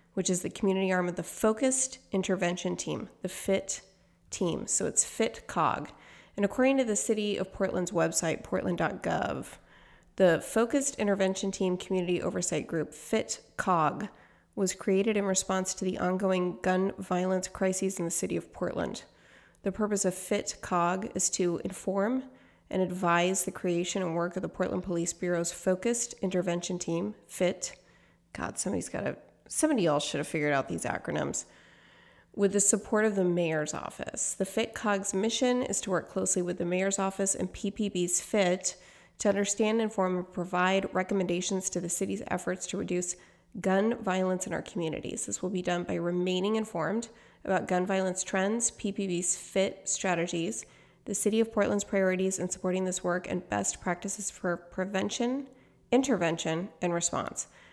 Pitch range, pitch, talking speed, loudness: 180-205 Hz, 185 Hz, 160 wpm, -30 LUFS